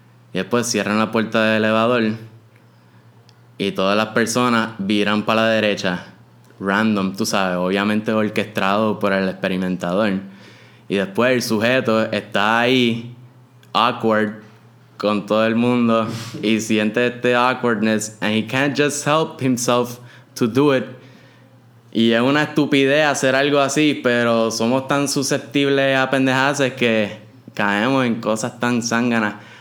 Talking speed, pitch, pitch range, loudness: 135 wpm, 115 Hz, 110-125 Hz, -18 LUFS